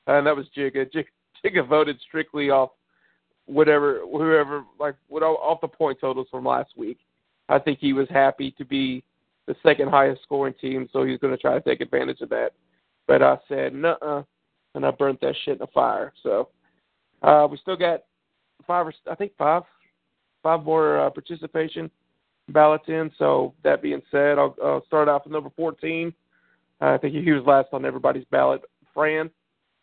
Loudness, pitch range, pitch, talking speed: -22 LUFS, 135-160 Hz, 145 Hz, 185 wpm